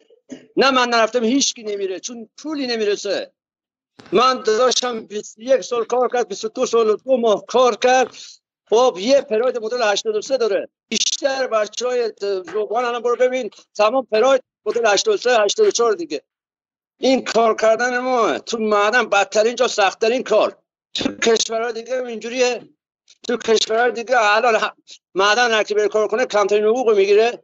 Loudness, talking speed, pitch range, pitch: -18 LUFS, 150 wpm, 215-255 Hz, 240 Hz